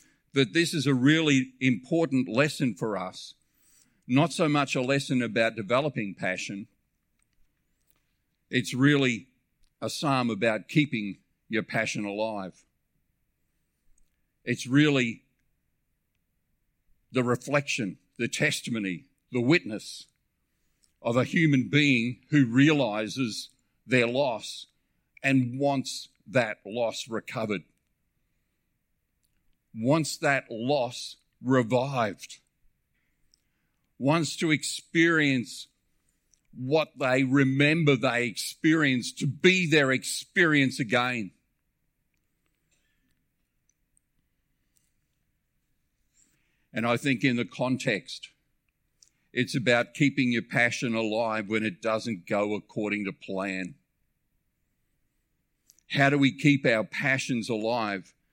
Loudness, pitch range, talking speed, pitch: -26 LUFS, 115-145 Hz, 95 wpm, 130 Hz